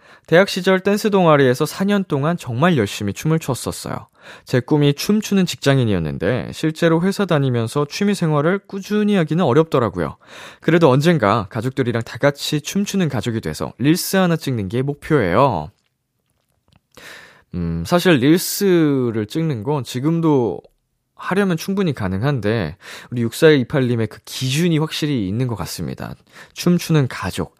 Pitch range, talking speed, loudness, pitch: 120-175 Hz, 320 characters per minute, -18 LUFS, 150 Hz